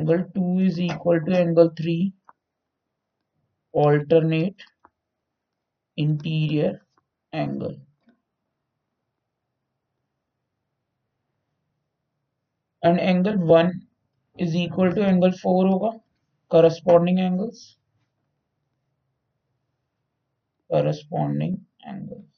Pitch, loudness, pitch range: 160 Hz, -21 LUFS, 135-180 Hz